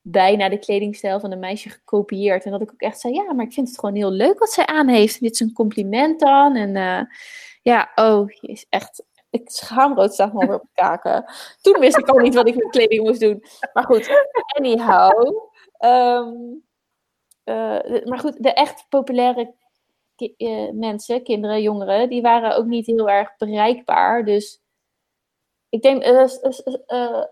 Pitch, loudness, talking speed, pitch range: 235 Hz, -18 LUFS, 185 wpm, 210-270 Hz